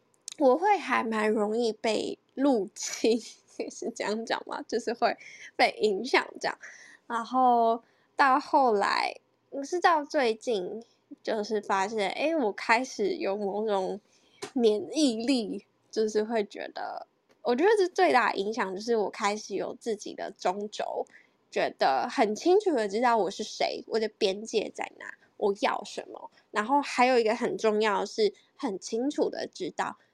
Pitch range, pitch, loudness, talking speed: 215-285 Hz, 230 Hz, -28 LUFS, 215 characters per minute